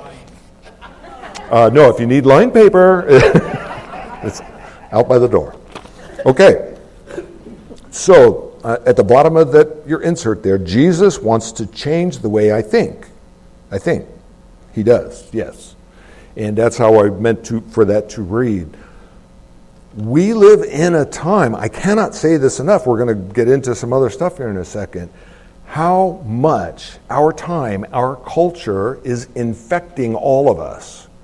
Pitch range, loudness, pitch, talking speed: 110-170 Hz, -13 LUFS, 125 Hz, 150 wpm